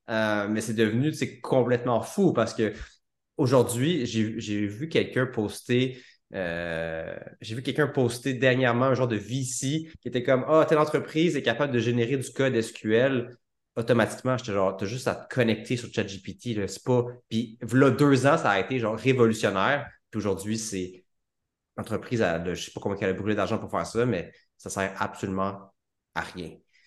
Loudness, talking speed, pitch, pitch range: -26 LUFS, 190 wpm, 115 Hz, 105-130 Hz